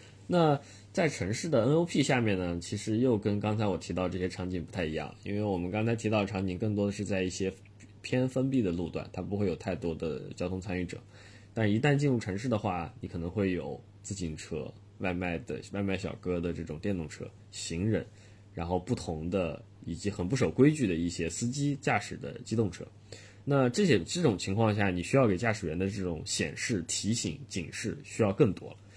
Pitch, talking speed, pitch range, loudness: 100 Hz, 305 characters per minute, 90-115 Hz, -31 LUFS